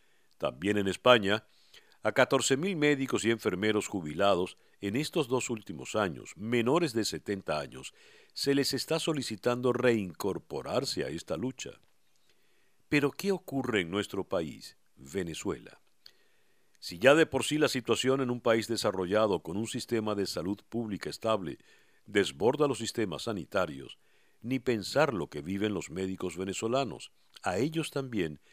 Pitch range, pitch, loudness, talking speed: 100-135 Hz, 115 Hz, -31 LUFS, 140 wpm